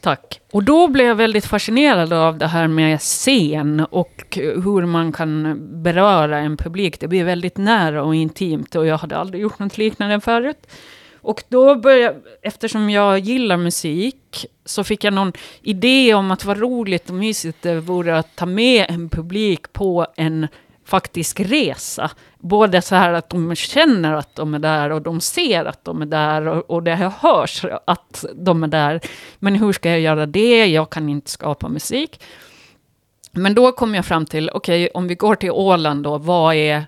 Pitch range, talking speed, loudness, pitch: 160-210 Hz, 185 wpm, -17 LUFS, 180 Hz